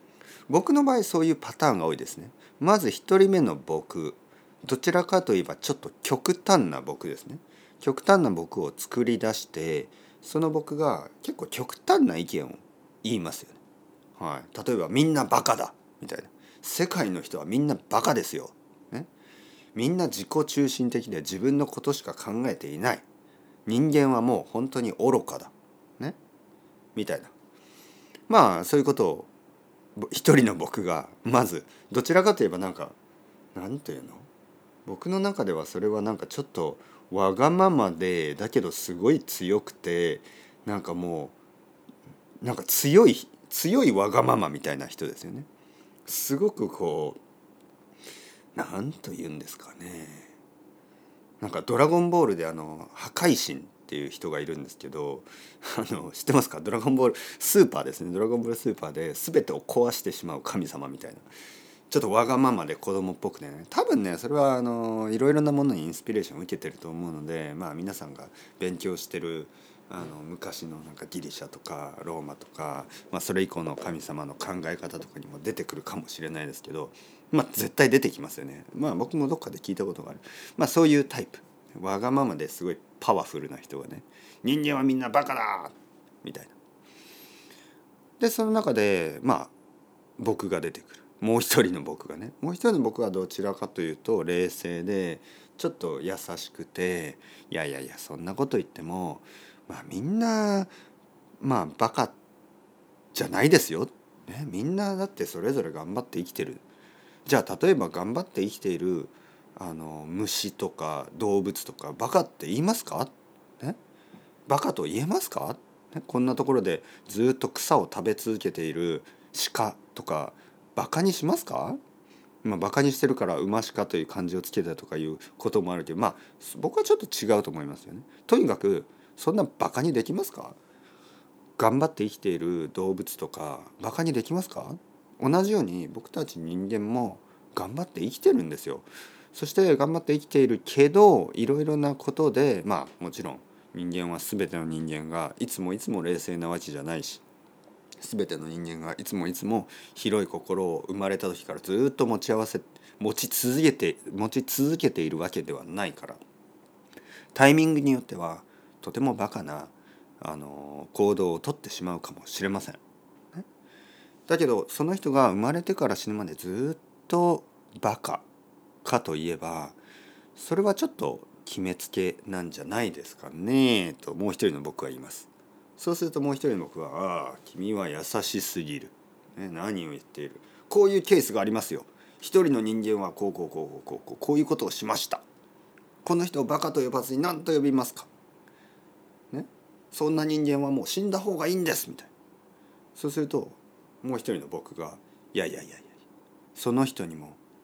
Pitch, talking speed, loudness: 125 Hz, 330 characters per minute, -27 LUFS